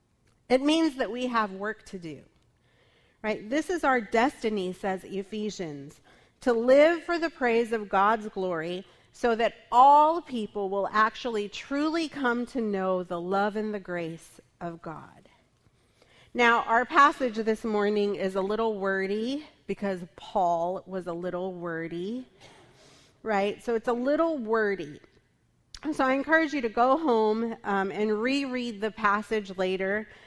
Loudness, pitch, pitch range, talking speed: -27 LUFS, 220 Hz, 195-250 Hz, 145 wpm